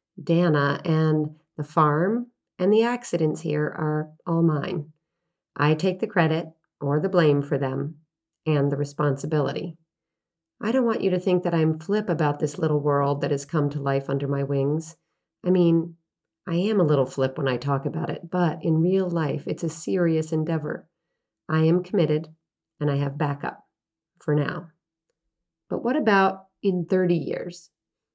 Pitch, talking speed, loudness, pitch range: 160 Hz, 170 wpm, -24 LUFS, 145-175 Hz